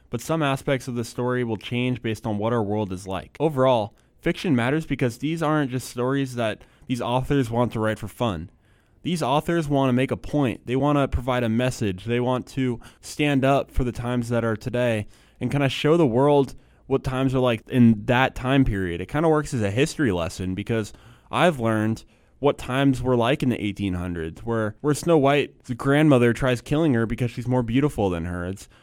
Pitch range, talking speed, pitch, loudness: 110-140 Hz, 210 wpm, 125 Hz, -23 LUFS